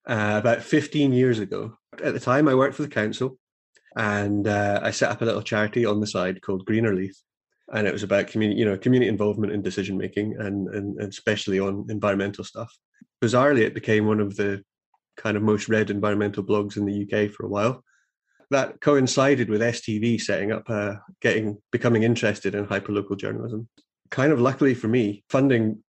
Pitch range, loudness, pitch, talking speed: 100-115 Hz, -24 LUFS, 105 Hz, 190 wpm